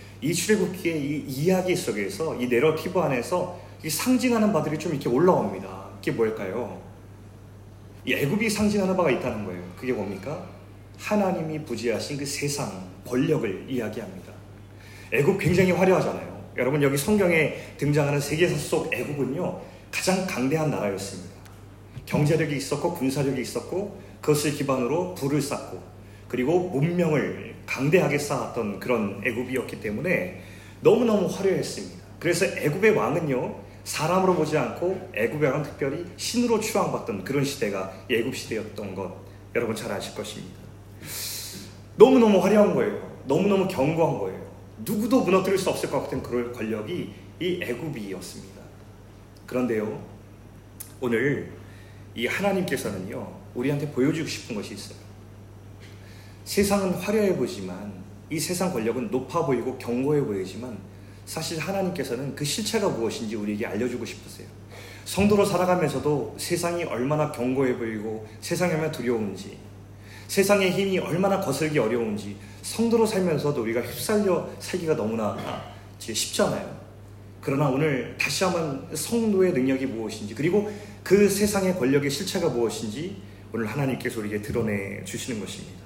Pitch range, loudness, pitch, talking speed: 100-170 Hz, -25 LUFS, 125 Hz, 345 characters per minute